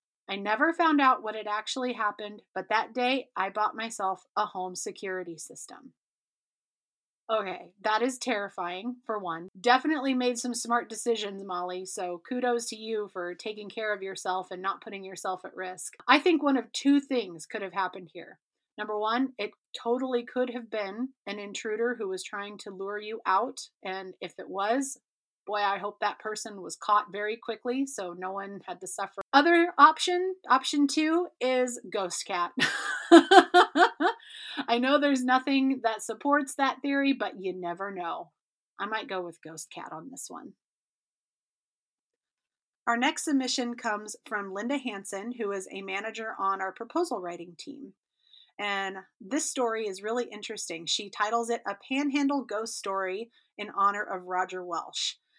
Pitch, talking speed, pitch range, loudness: 215 Hz, 165 wpm, 195-255 Hz, -28 LUFS